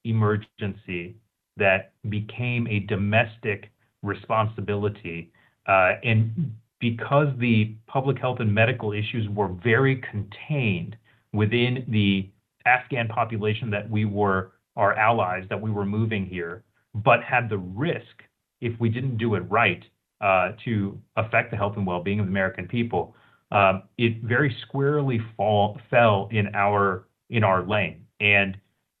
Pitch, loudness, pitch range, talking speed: 110 Hz, -24 LUFS, 100-120 Hz, 135 wpm